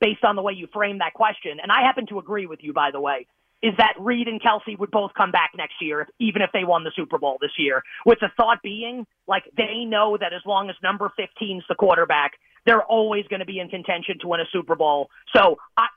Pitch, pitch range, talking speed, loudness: 205 Hz, 180-225 Hz, 255 wpm, -22 LUFS